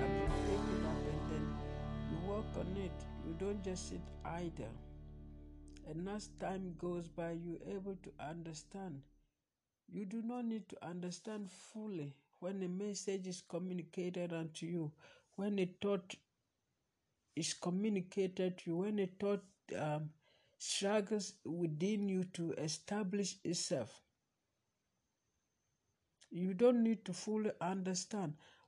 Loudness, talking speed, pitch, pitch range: -41 LUFS, 130 wpm, 180 Hz, 150-200 Hz